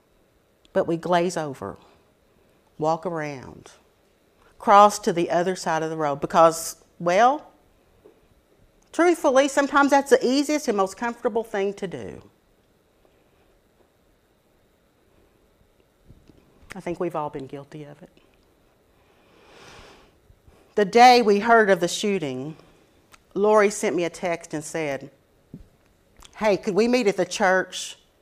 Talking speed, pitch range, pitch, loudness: 120 wpm, 155-220 Hz, 180 Hz, -21 LUFS